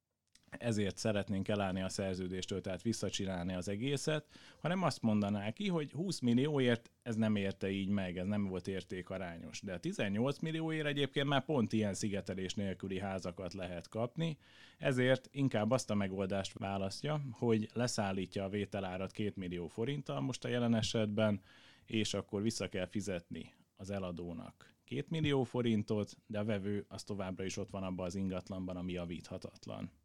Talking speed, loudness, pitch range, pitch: 155 wpm, -38 LUFS, 95-120 Hz, 105 Hz